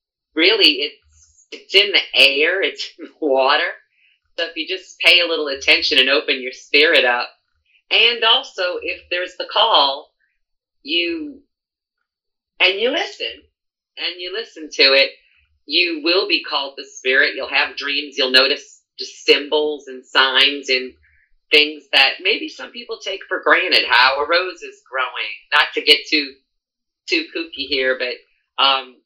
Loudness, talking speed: -16 LUFS, 155 wpm